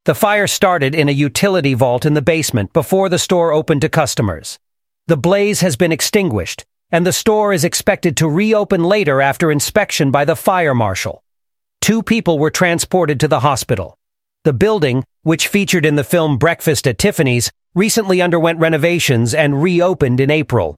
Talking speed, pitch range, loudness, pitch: 170 wpm, 145-185 Hz, -14 LUFS, 165 Hz